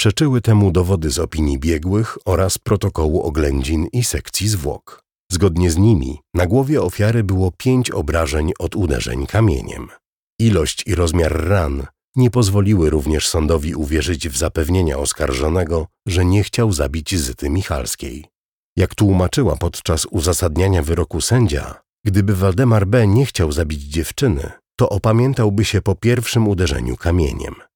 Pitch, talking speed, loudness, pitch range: 90 Hz, 135 wpm, -17 LUFS, 80-105 Hz